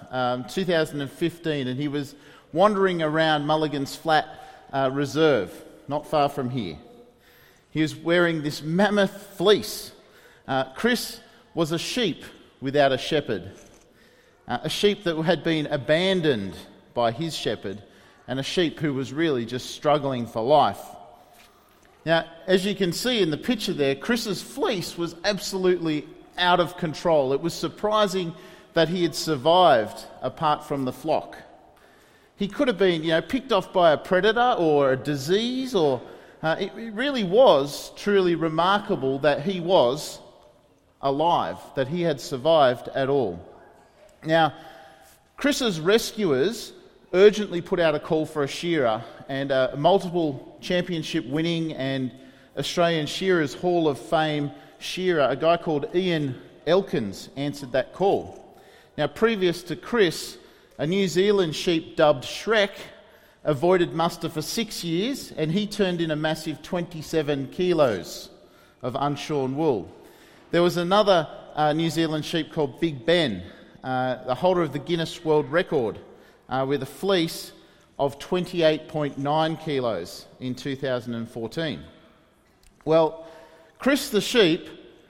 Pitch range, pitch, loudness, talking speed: 145-185 Hz, 160 Hz, -24 LUFS, 140 wpm